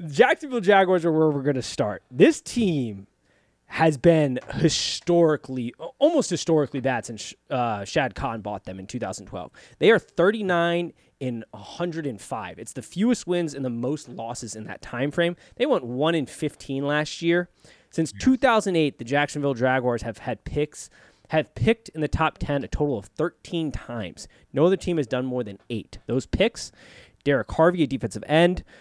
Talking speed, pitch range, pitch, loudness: 175 wpm, 125-170 Hz, 150 Hz, -24 LUFS